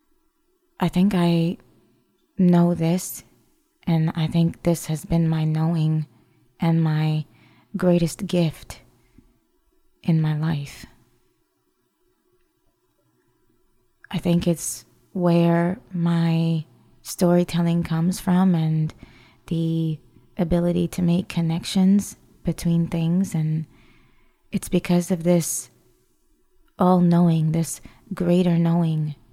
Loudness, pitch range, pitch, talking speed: -22 LUFS, 155-185 Hz, 170 Hz, 95 wpm